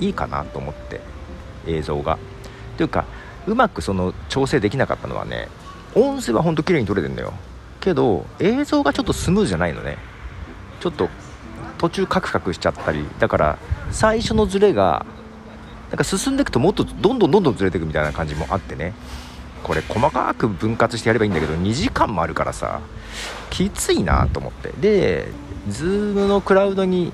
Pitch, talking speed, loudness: 110 Hz, 370 characters per minute, -20 LUFS